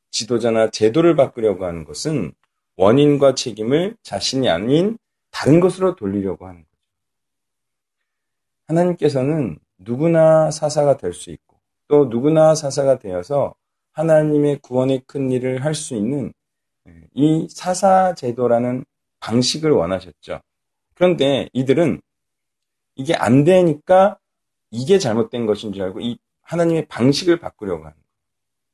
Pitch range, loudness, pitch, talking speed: 115-155 Hz, -18 LUFS, 135 Hz, 270 characters per minute